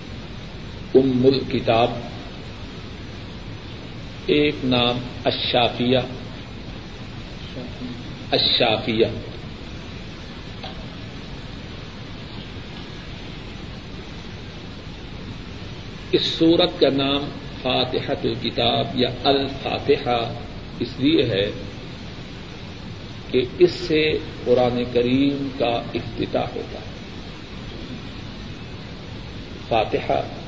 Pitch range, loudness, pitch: 120-135 Hz, -21 LUFS, 125 Hz